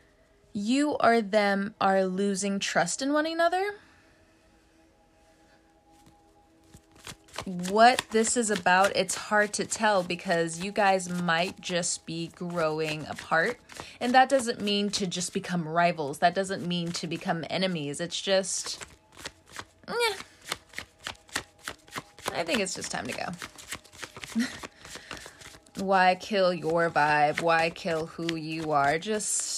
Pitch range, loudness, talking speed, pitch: 160-205 Hz, -27 LUFS, 120 wpm, 180 Hz